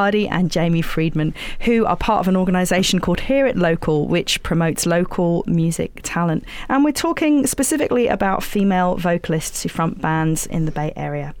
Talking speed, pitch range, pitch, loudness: 175 wpm, 165-200 Hz, 175 Hz, -19 LUFS